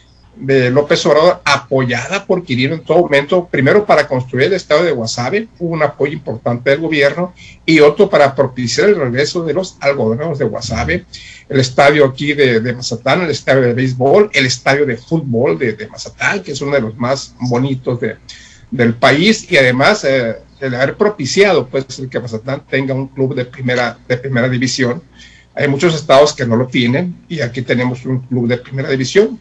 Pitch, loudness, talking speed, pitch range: 135 Hz, -14 LUFS, 190 wpm, 125-150 Hz